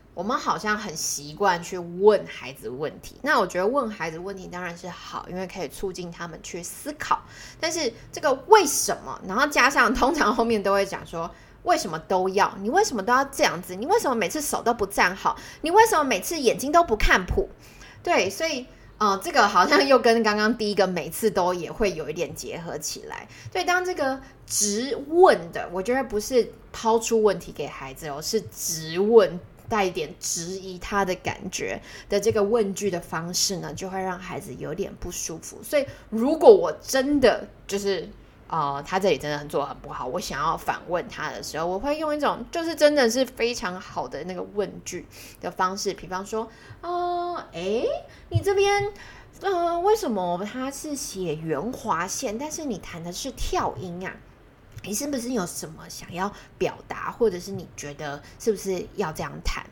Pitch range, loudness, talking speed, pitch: 180-275 Hz, -24 LUFS, 275 characters per minute, 210 Hz